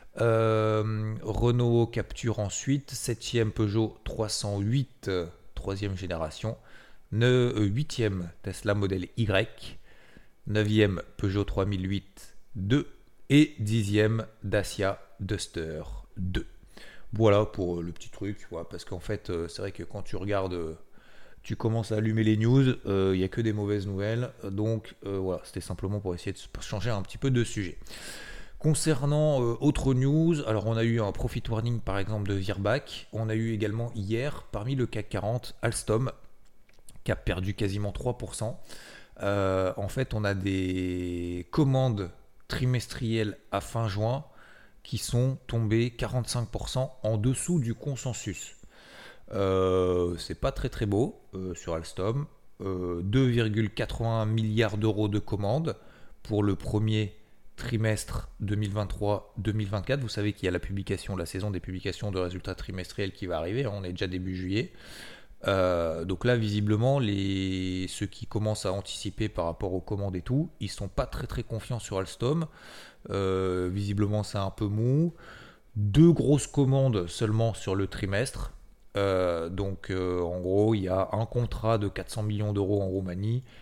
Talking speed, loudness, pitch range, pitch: 150 wpm, -29 LUFS, 95-115 Hz, 105 Hz